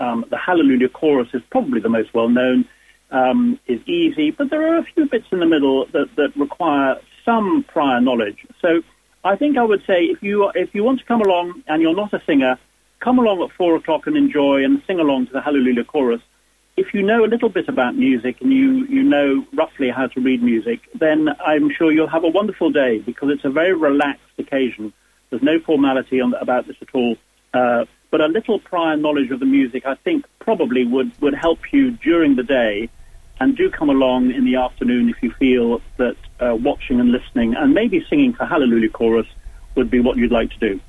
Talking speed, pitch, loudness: 215 wpm, 155 Hz, -18 LUFS